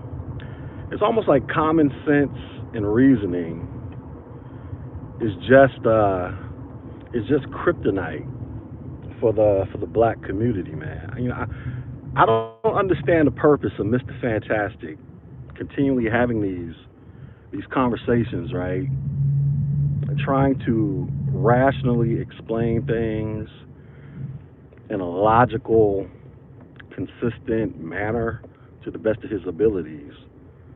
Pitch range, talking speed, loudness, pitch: 110-135 Hz, 105 wpm, -22 LUFS, 125 Hz